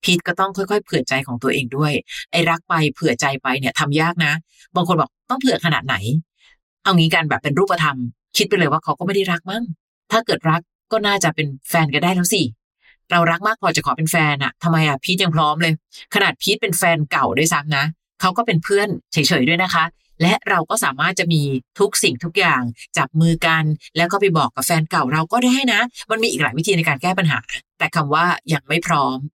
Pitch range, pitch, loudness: 150-190 Hz, 170 Hz, -18 LUFS